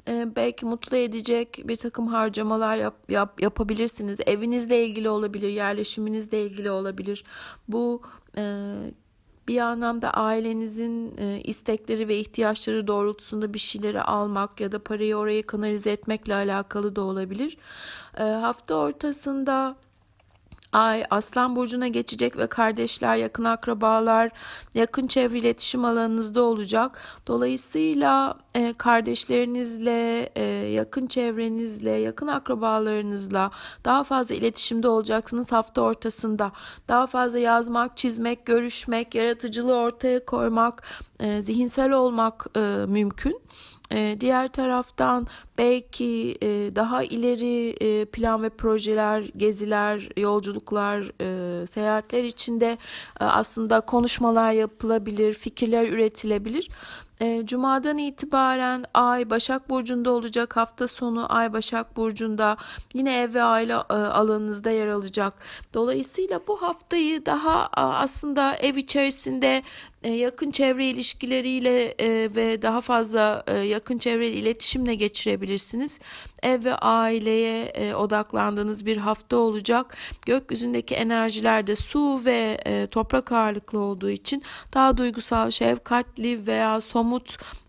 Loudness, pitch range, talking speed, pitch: -24 LUFS, 210-245 Hz, 100 wpm, 225 Hz